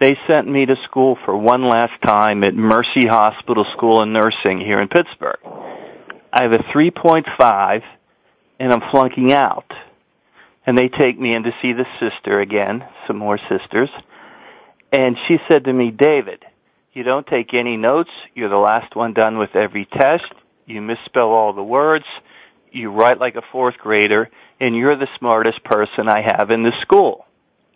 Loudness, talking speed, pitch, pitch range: -16 LUFS, 170 wpm, 120 Hz, 110-135 Hz